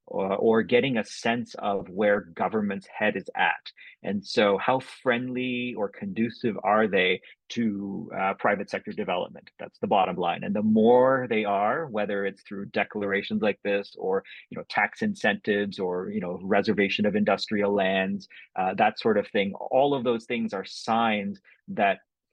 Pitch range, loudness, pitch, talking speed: 100-120 Hz, -26 LUFS, 105 Hz, 170 wpm